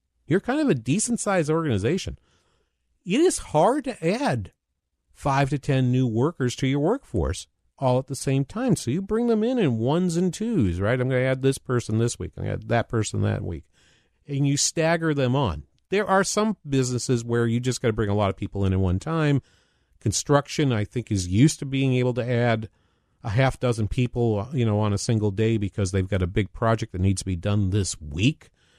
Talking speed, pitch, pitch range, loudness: 225 wpm, 125 Hz, 105-145 Hz, -24 LUFS